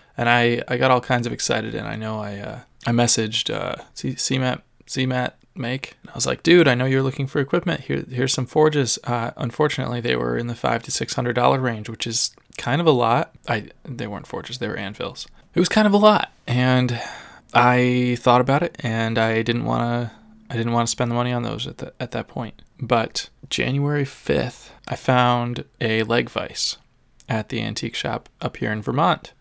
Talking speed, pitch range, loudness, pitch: 210 wpm, 120-135 Hz, -21 LUFS, 125 Hz